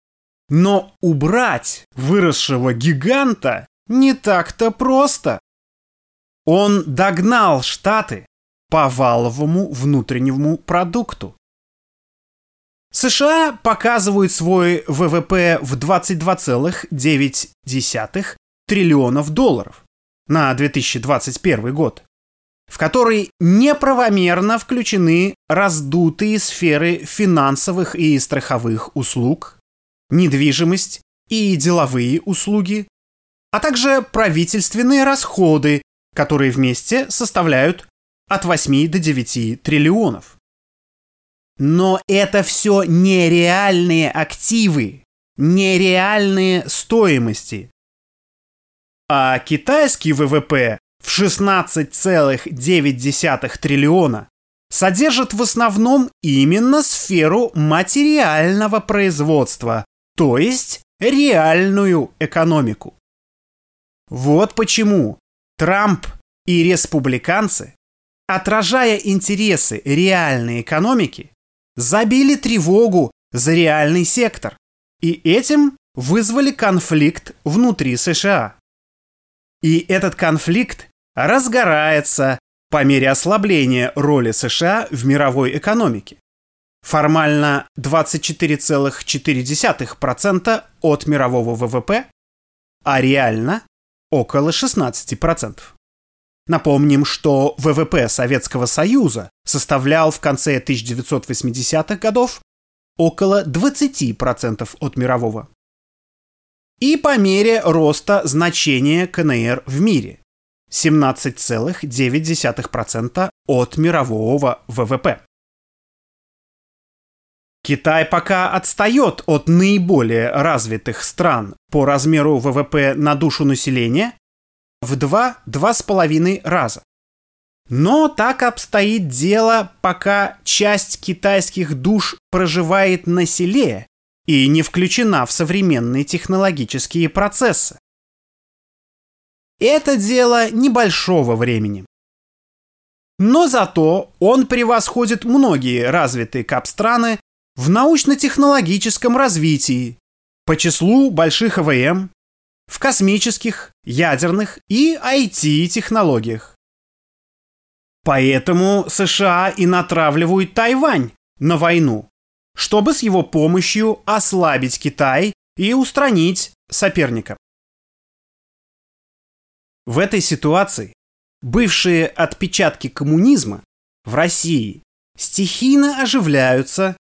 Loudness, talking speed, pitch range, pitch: -15 LUFS, 75 wpm, 140-200 Hz, 165 Hz